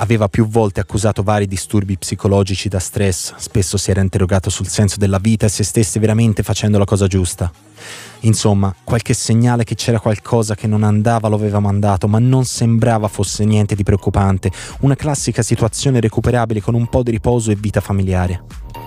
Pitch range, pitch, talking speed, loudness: 100-115 Hz, 105 Hz, 180 wpm, -16 LUFS